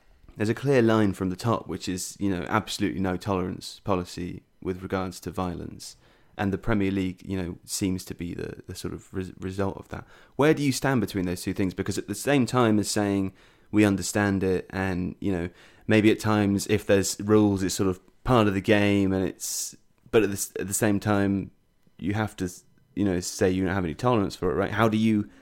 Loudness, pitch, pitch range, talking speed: -26 LUFS, 100 Hz, 95-105 Hz, 225 wpm